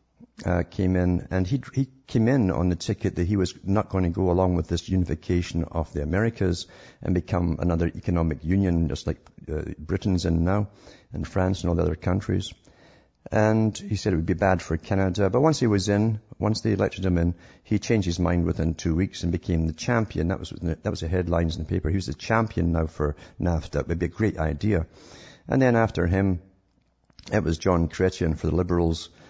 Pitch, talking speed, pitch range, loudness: 90 Hz, 220 wpm, 85-100 Hz, -25 LUFS